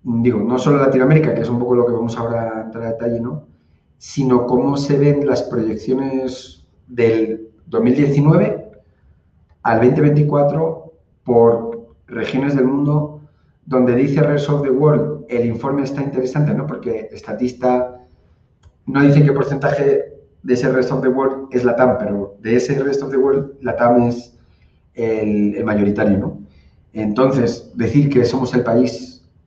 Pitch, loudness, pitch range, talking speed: 125 Hz, -17 LUFS, 115-140 Hz, 155 wpm